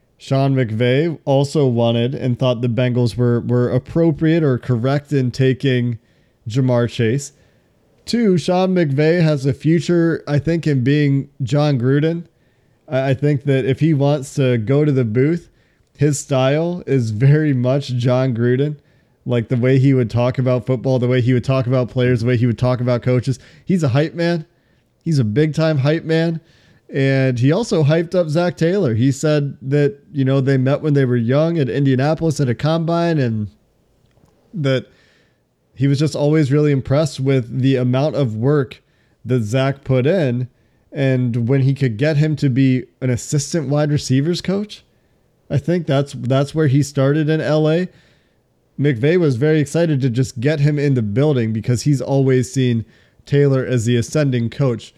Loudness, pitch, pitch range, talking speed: -17 LUFS, 135 Hz, 125-150 Hz, 175 wpm